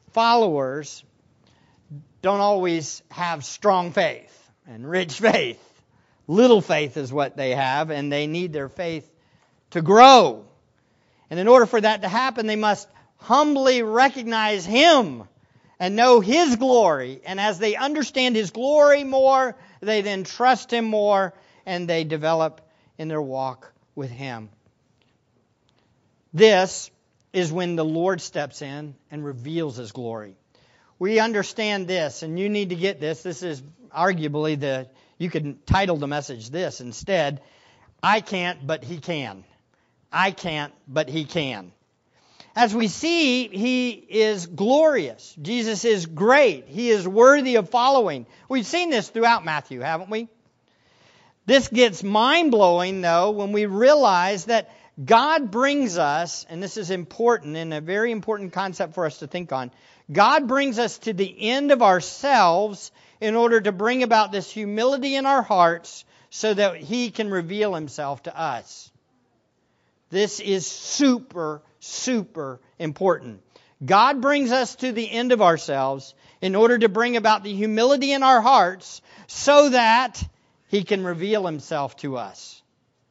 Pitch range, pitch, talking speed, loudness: 150-230 Hz, 190 Hz, 145 wpm, -21 LUFS